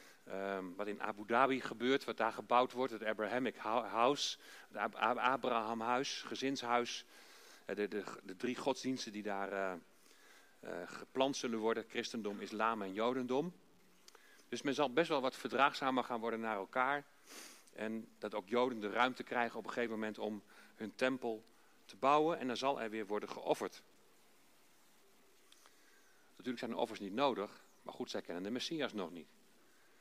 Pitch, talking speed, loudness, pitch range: 120 Hz, 160 wpm, -38 LUFS, 110-130 Hz